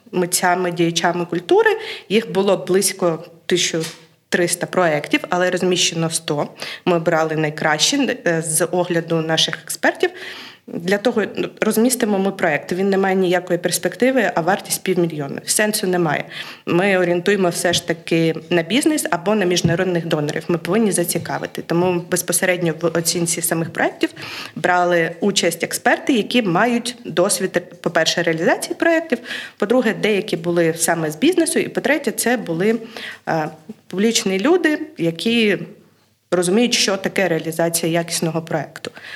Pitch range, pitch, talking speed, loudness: 170-210 Hz, 180 Hz, 125 wpm, -18 LUFS